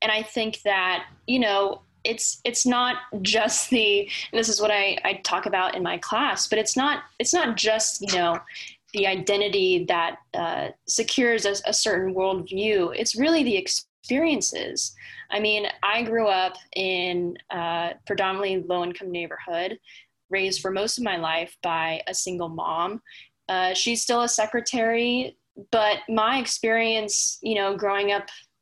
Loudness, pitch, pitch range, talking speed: -24 LUFS, 210 Hz, 190-230 Hz, 160 wpm